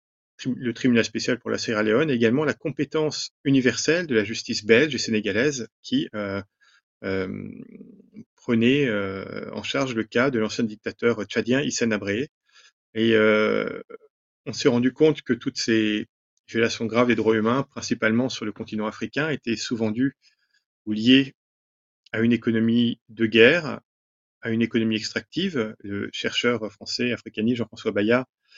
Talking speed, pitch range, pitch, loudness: 150 wpm, 110-130 Hz, 115 Hz, -23 LUFS